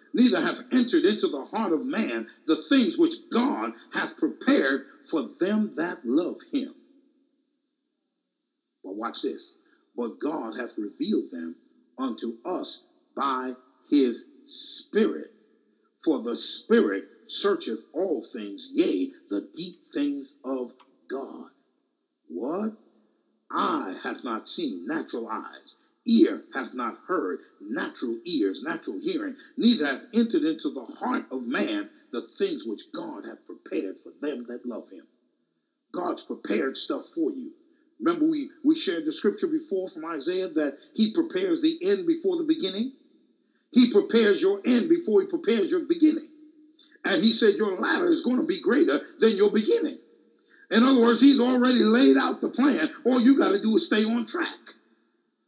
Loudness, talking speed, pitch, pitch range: -25 LUFS, 150 wpm, 305 Hz, 250-330 Hz